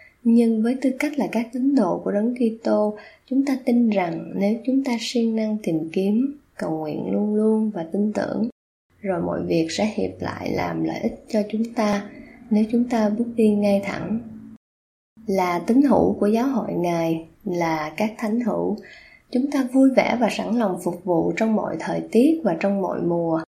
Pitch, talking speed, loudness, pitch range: 220 Hz, 195 wpm, -22 LUFS, 190-235 Hz